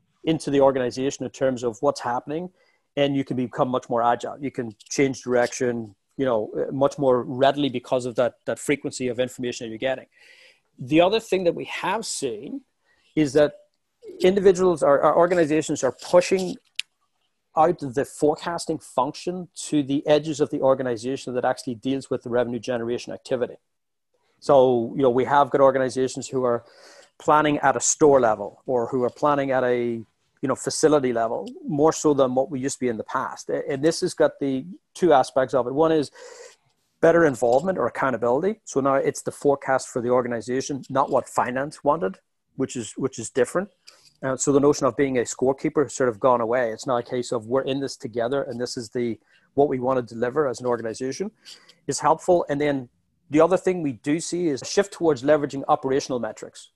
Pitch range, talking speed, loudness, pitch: 125-155 Hz, 195 wpm, -23 LUFS, 135 Hz